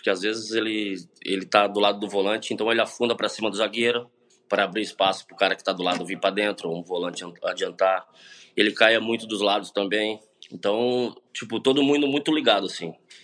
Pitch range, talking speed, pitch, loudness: 95-115 Hz, 205 wpm, 105 Hz, -24 LUFS